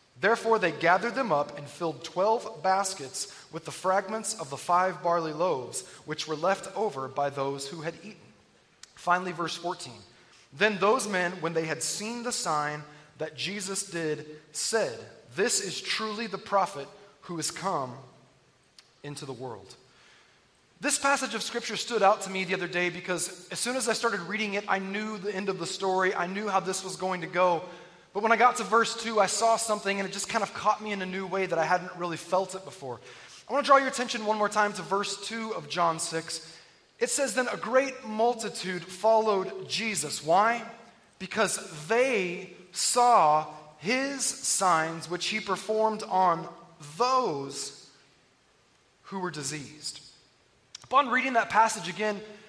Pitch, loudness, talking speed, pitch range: 190 Hz, -28 LUFS, 180 wpm, 165-220 Hz